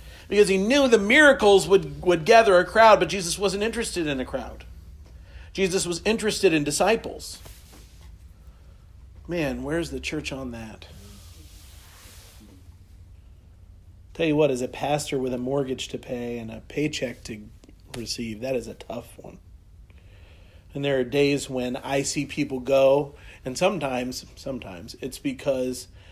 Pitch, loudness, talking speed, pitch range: 125 Hz, -23 LUFS, 145 wpm, 90-150 Hz